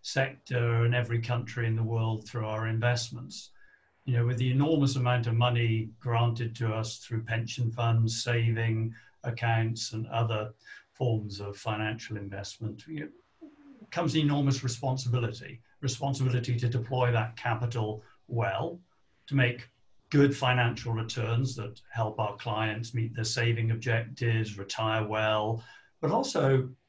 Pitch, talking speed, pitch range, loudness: 115 Hz, 130 wpm, 110-125 Hz, -30 LUFS